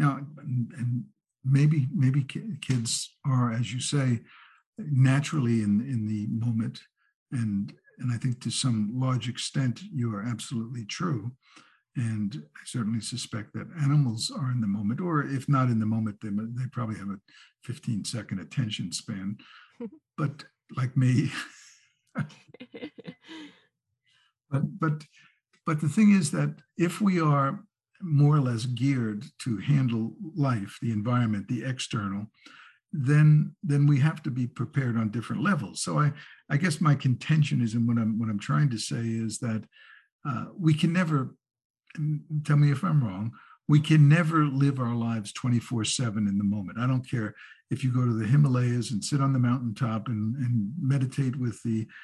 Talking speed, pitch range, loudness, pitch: 165 wpm, 115-145 Hz, -27 LUFS, 130 Hz